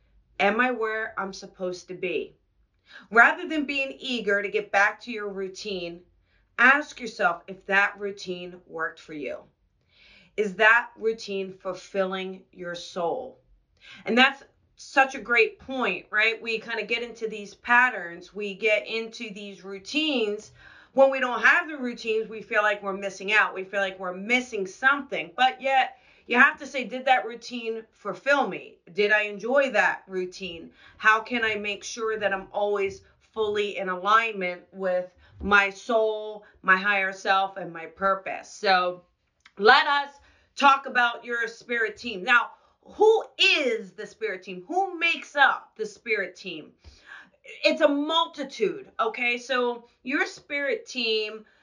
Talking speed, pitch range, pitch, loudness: 155 wpm, 195-260 Hz, 220 Hz, -24 LUFS